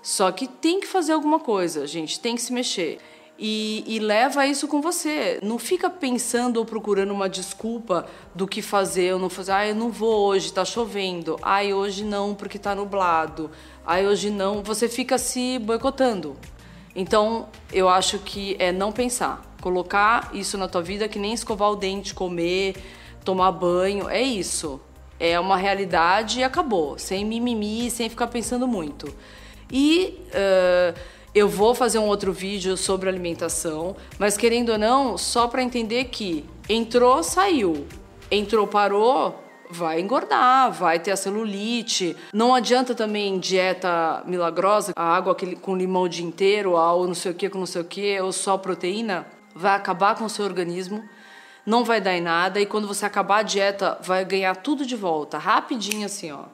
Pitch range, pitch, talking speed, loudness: 185-230 Hz, 200 Hz, 170 wpm, -23 LUFS